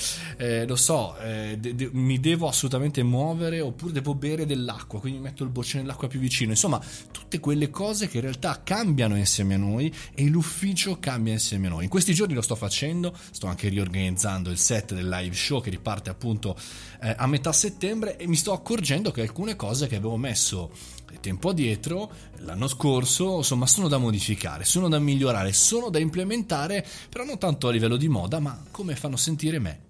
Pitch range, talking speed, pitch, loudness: 110-160 Hz, 195 wpm, 135 Hz, -25 LUFS